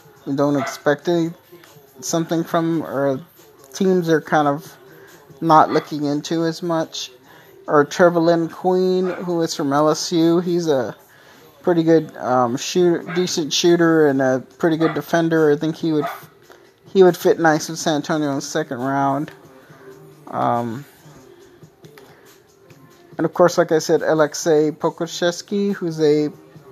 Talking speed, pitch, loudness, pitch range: 140 wpm, 160 Hz, -19 LUFS, 145-170 Hz